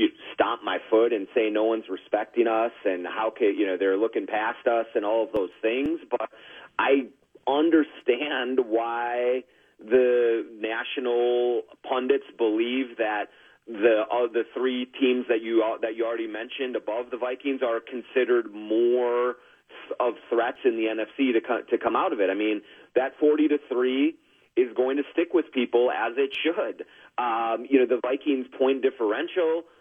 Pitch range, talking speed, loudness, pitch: 115-140 Hz, 170 wpm, -25 LUFS, 125 Hz